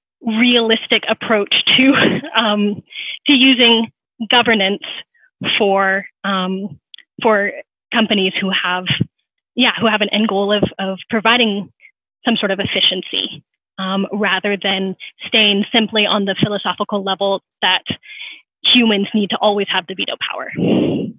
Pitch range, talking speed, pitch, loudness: 195-230 Hz, 125 wpm, 210 Hz, -15 LUFS